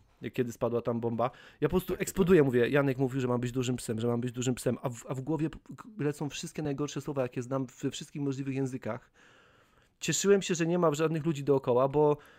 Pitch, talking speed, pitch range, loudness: 140 Hz, 220 wpm, 125-160 Hz, -30 LUFS